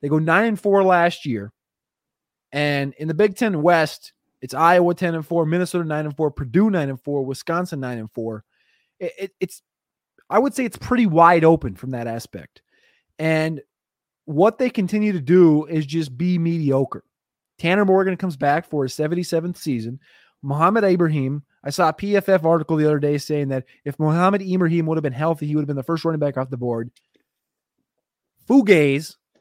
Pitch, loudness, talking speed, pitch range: 160 Hz, -20 LUFS, 185 wpm, 145-180 Hz